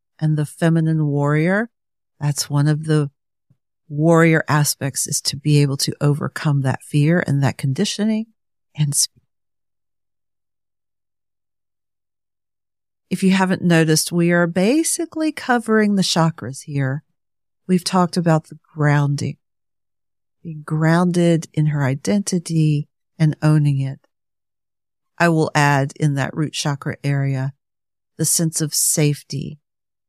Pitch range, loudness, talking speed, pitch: 135-165 Hz, -19 LUFS, 120 wpm, 150 Hz